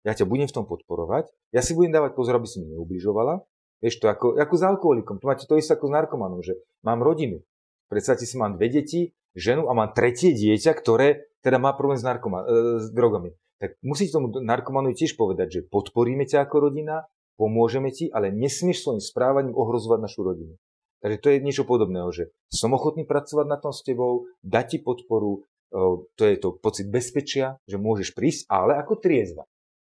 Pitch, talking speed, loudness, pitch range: 130 Hz, 195 wpm, -24 LUFS, 115-150 Hz